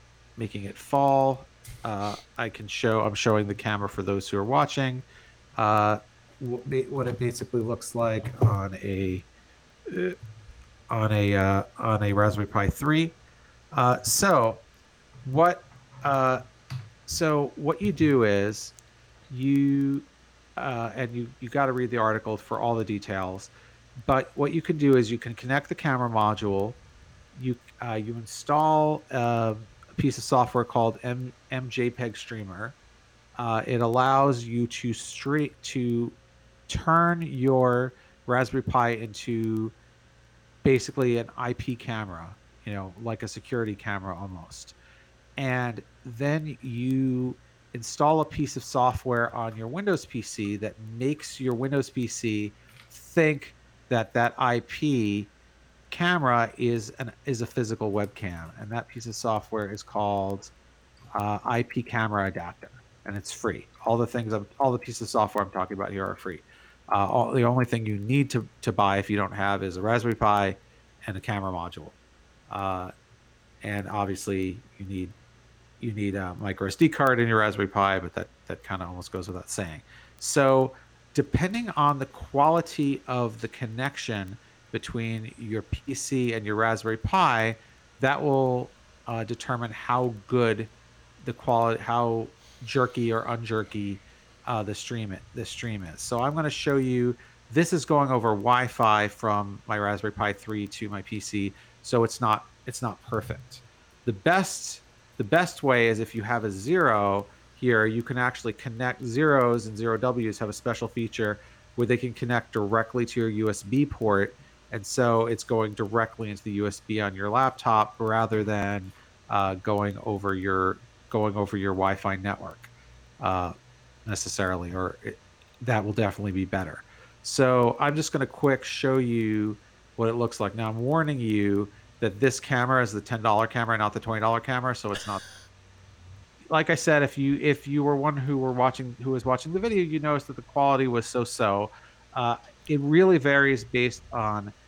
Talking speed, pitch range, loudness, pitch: 160 wpm, 105-125 Hz, -27 LUFS, 115 Hz